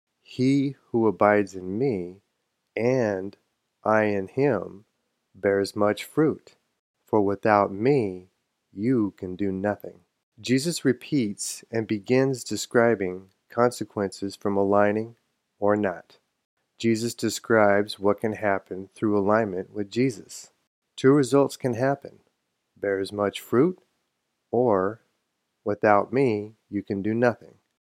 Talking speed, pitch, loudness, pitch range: 110 wpm, 105 Hz, -25 LUFS, 100-120 Hz